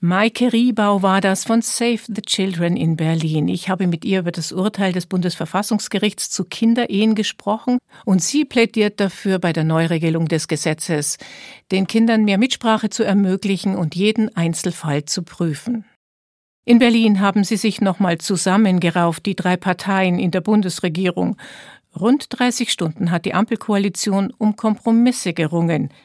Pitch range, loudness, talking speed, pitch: 175-220 Hz, -18 LUFS, 145 wpm, 195 Hz